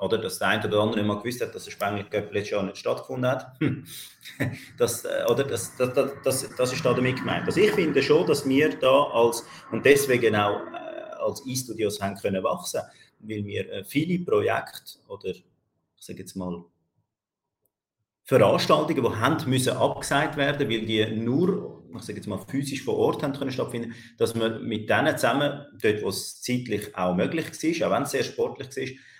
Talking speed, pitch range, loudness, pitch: 185 wpm, 105-140 Hz, -25 LUFS, 120 Hz